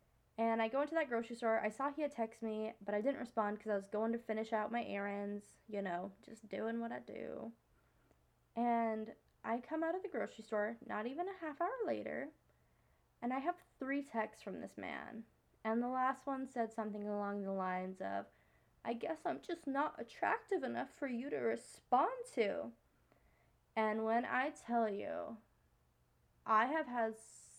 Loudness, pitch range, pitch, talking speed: -40 LUFS, 210-265 Hz, 225 Hz, 185 wpm